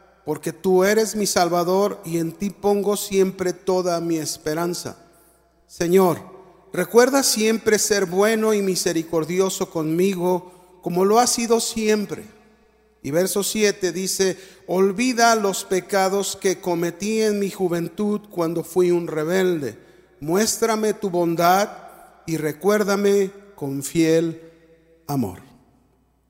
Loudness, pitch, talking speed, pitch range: -21 LUFS, 185 Hz, 115 wpm, 170-205 Hz